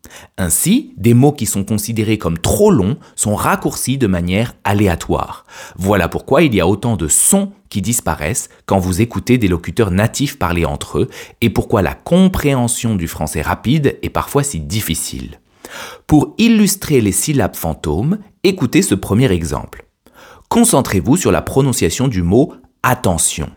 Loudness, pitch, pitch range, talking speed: -15 LUFS, 105 Hz, 90-130 Hz, 155 wpm